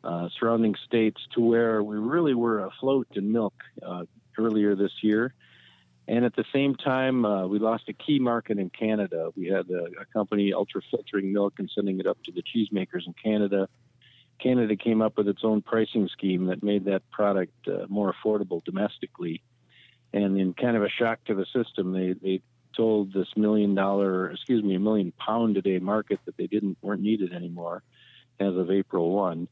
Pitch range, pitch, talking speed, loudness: 95-115 Hz, 105 Hz, 185 wpm, -27 LUFS